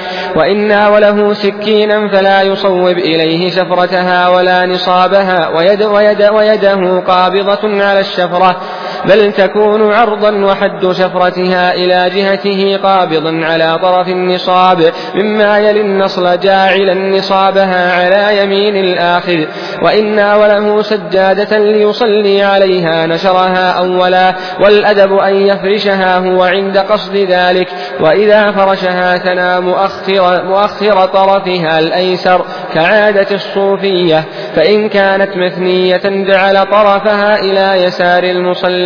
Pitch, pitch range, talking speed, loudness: 195 Hz, 180-200 Hz, 100 wpm, -9 LUFS